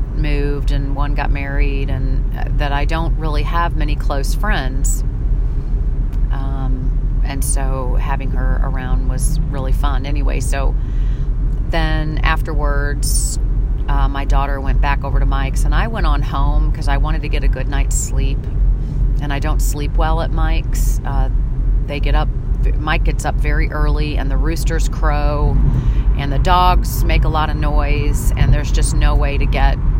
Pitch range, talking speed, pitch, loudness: 130-150 Hz, 170 wpm, 140 Hz, -19 LUFS